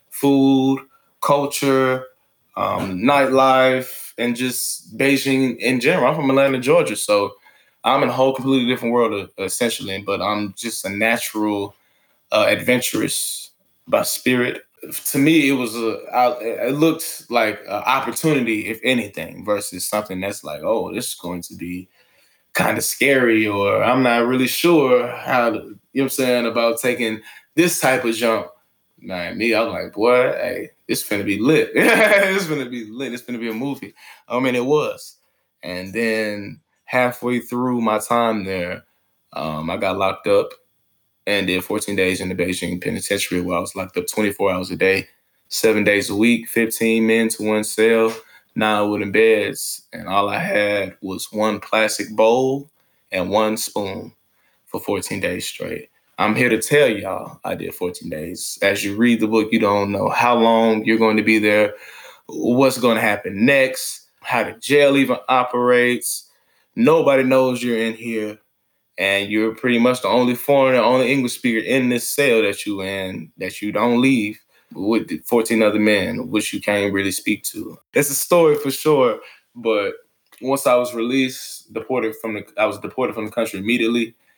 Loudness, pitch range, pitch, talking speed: -19 LUFS, 105-130 Hz, 120 Hz, 175 wpm